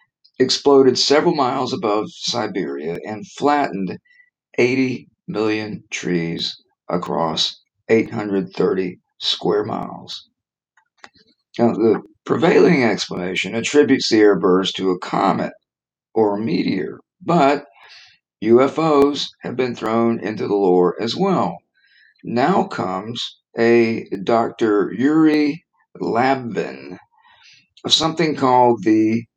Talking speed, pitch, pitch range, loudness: 100 wpm, 125 Hz, 110-145 Hz, -18 LUFS